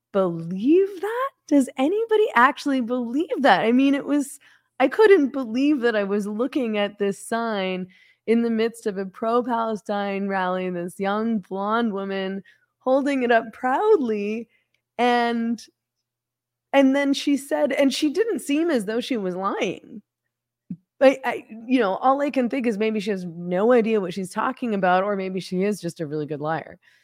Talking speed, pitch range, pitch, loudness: 175 wpm, 195-270 Hz, 225 Hz, -22 LUFS